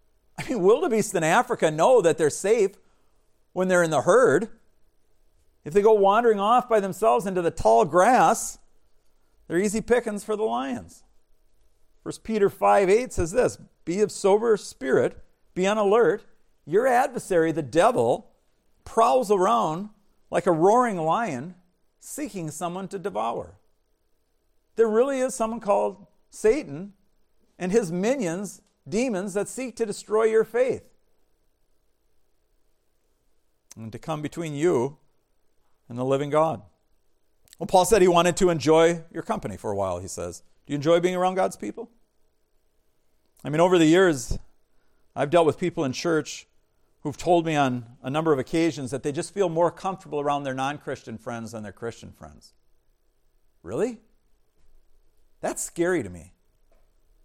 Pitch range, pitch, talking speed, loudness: 150-220 Hz, 185 Hz, 150 wpm, -23 LUFS